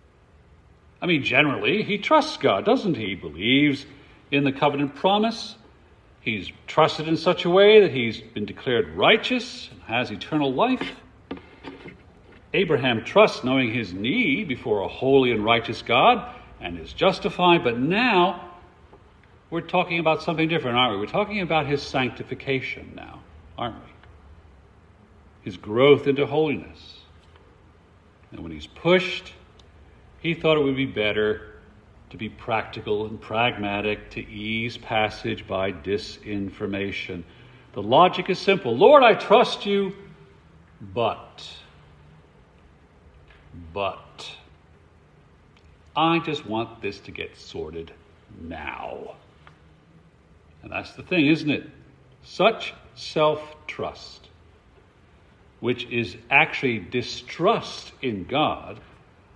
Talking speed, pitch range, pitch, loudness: 120 wpm, 95-155 Hz, 115 Hz, -22 LUFS